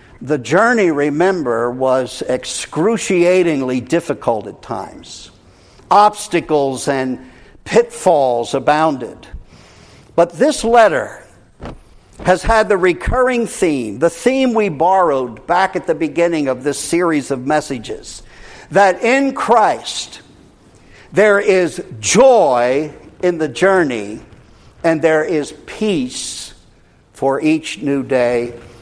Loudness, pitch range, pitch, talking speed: -15 LUFS, 125-185 Hz, 155 Hz, 105 wpm